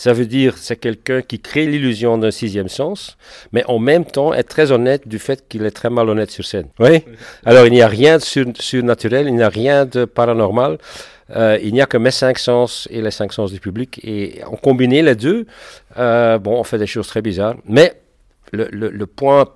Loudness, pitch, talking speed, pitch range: -15 LUFS, 120 Hz, 220 wpm, 110-130 Hz